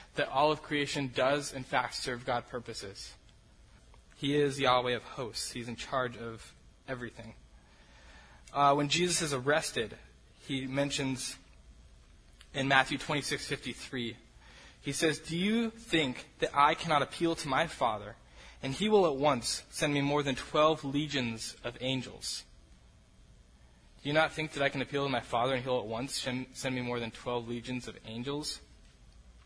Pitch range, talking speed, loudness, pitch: 115-145 Hz, 165 wpm, -32 LUFS, 130 Hz